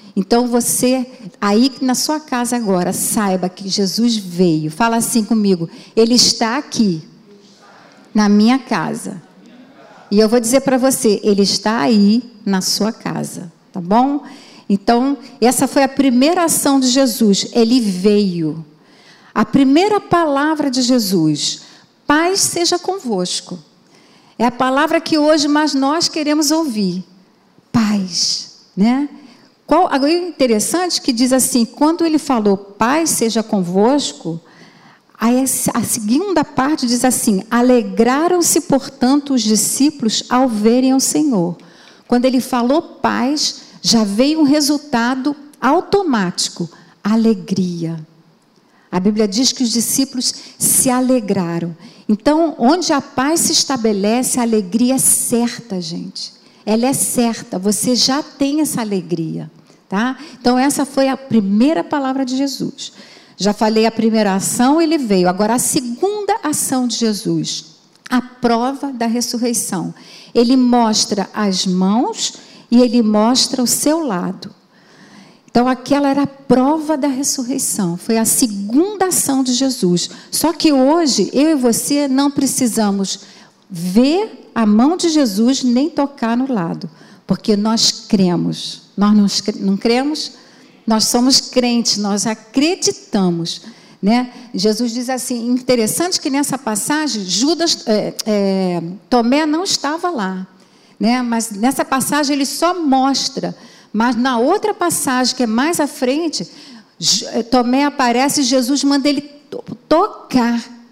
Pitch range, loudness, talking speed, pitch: 210-275 Hz, -15 LUFS, 130 wpm, 245 Hz